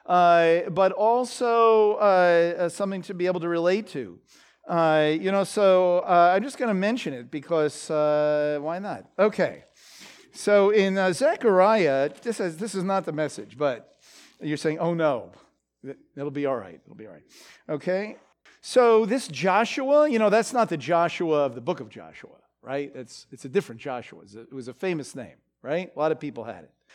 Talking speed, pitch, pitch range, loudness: 190 wpm, 175 Hz, 150-200 Hz, -23 LUFS